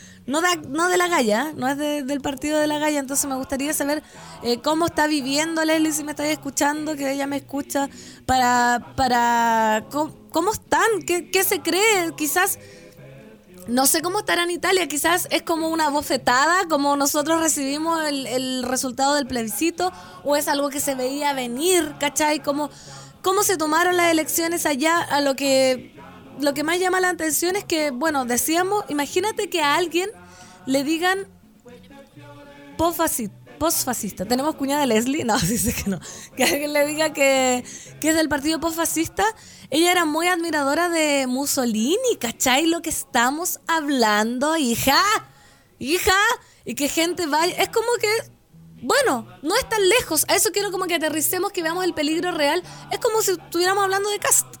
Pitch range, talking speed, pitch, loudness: 275-345 Hz, 170 wpm, 305 Hz, -21 LUFS